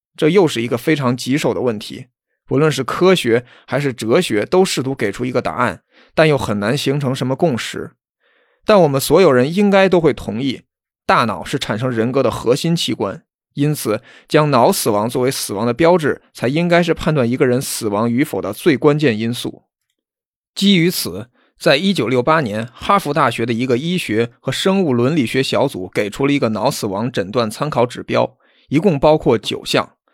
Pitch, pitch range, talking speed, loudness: 135 Hz, 120-160 Hz, 275 characters per minute, -16 LUFS